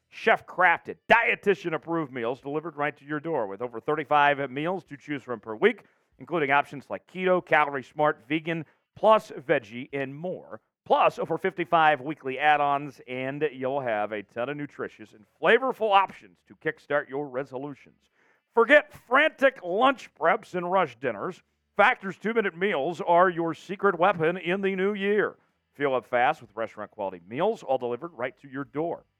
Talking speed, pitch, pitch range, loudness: 160 wpm, 155 Hz, 135-185 Hz, -26 LUFS